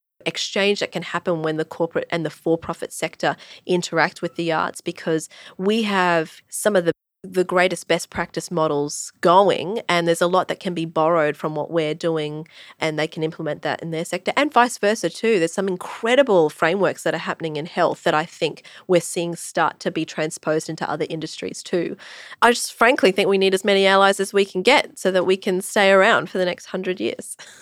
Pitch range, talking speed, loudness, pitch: 160-190 Hz, 210 wpm, -21 LUFS, 175 Hz